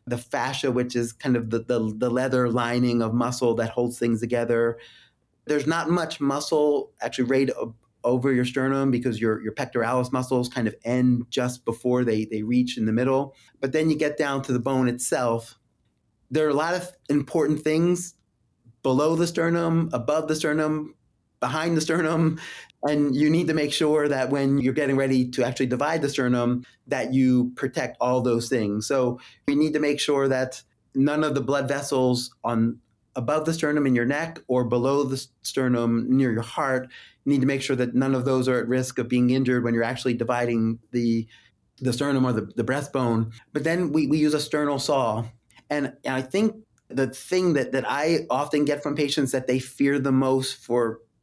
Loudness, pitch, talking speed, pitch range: -24 LUFS, 130 Hz, 195 wpm, 120-145 Hz